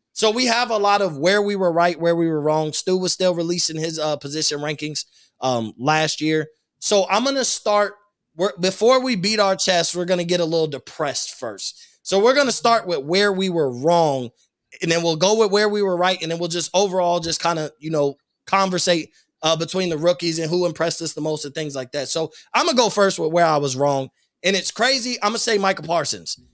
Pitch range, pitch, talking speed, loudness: 155-200 Hz, 175 Hz, 245 wpm, -20 LUFS